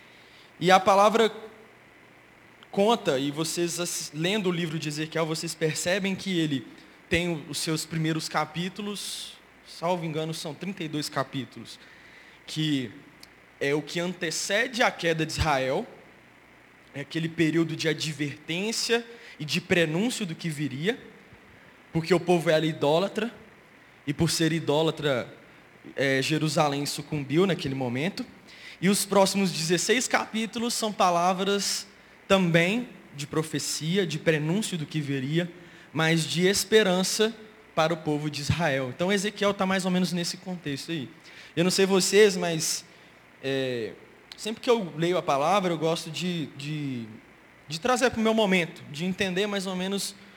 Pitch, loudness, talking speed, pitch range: 170 Hz, -26 LUFS, 140 wpm, 155-195 Hz